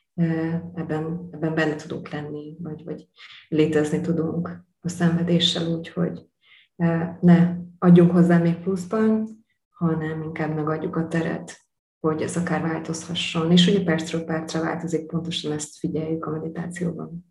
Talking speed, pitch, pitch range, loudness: 125 wpm, 165 Hz, 160-175 Hz, -23 LUFS